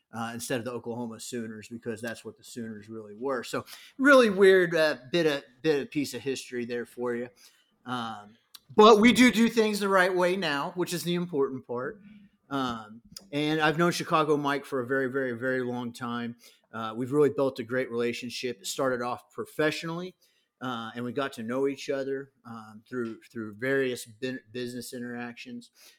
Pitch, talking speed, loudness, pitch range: 130 Hz, 185 wpm, -27 LUFS, 120-160 Hz